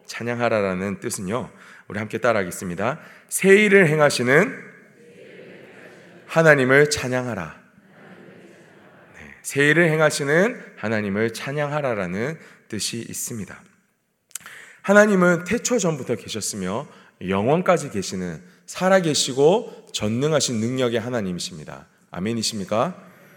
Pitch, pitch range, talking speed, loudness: 140 Hz, 110-175 Hz, 265 characters per minute, -21 LUFS